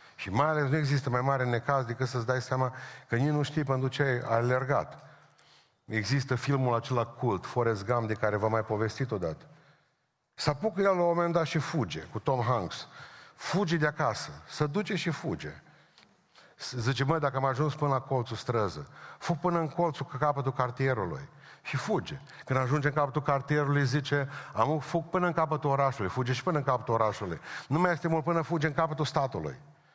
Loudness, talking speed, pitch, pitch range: -30 LUFS, 190 wpm, 140 Hz, 125-155 Hz